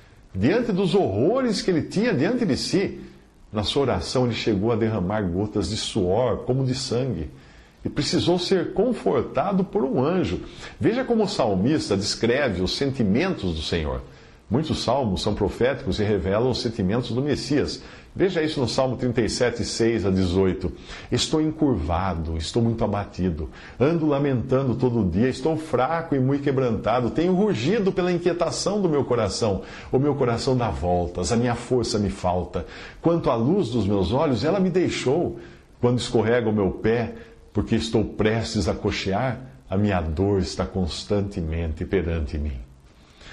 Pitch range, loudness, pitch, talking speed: 95-135 Hz, -23 LUFS, 115 Hz, 155 wpm